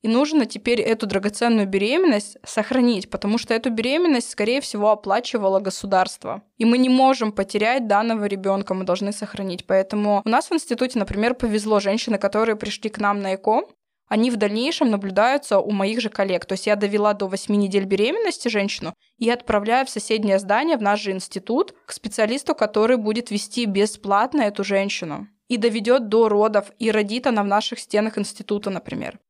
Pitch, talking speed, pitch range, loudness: 215 Hz, 175 wpm, 205-240 Hz, -21 LUFS